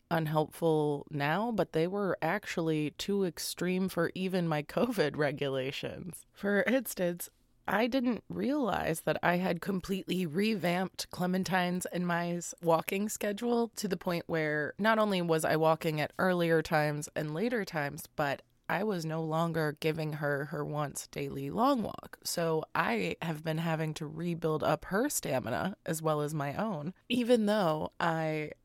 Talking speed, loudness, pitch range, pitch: 155 wpm, -32 LUFS, 155-195 Hz, 170 Hz